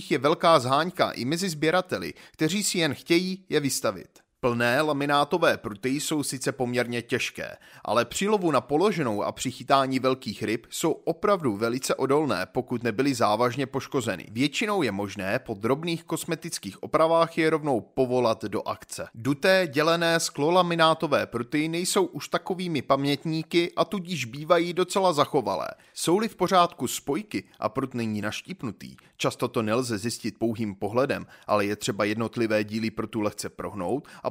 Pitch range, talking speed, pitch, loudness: 120-165 Hz, 145 wpm, 140 Hz, -26 LUFS